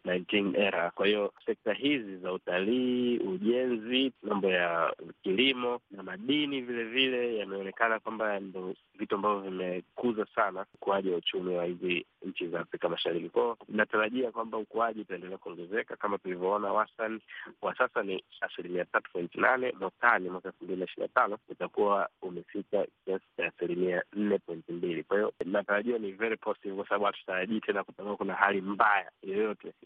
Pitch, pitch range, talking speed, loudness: 105 Hz, 95-120 Hz, 150 wpm, -31 LUFS